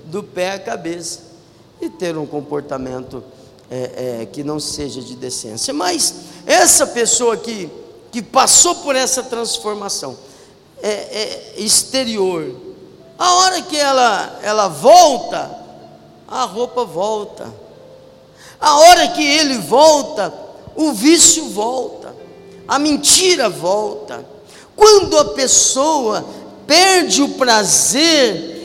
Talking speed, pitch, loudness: 110 wpm, 240 Hz, -13 LUFS